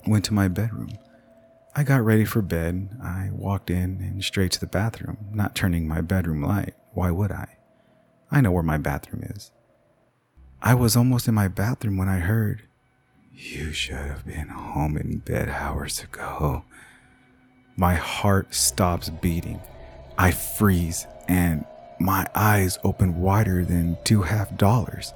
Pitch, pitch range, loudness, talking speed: 95 Hz, 85-110 Hz, -24 LUFS, 155 wpm